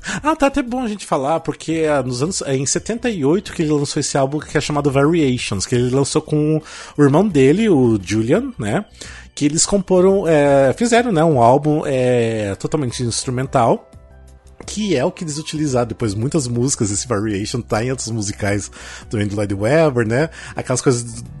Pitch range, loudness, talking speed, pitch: 115-160 Hz, -17 LUFS, 190 wpm, 140 Hz